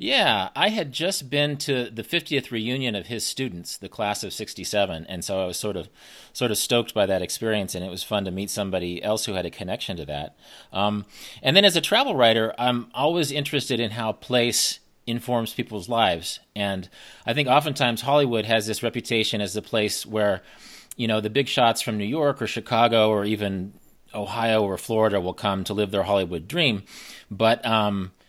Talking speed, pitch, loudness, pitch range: 200 wpm, 110 Hz, -24 LUFS, 100-125 Hz